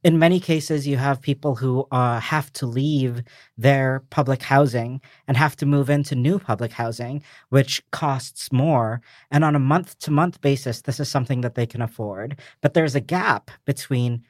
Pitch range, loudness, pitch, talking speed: 125-145 Hz, -22 LUFS, 140 Hz, 185 wpm